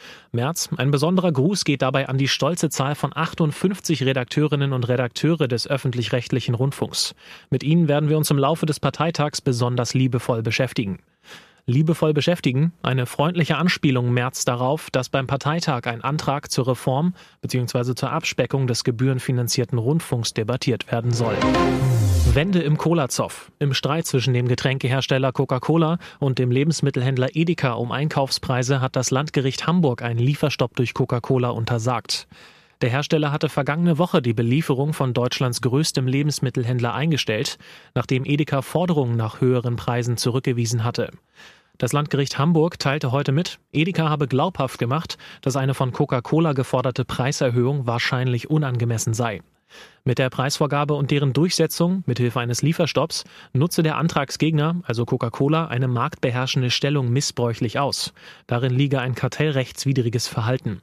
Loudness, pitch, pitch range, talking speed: -22 LUFS, 135 Hz, 125-150 Hz, 140 wpm